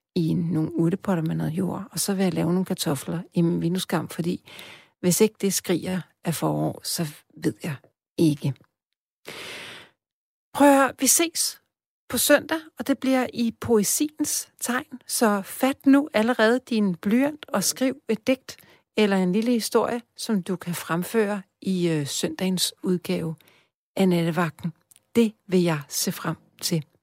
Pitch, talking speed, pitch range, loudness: 185 Hz, 155 wpm, 170-235 Hz, -24 LUFS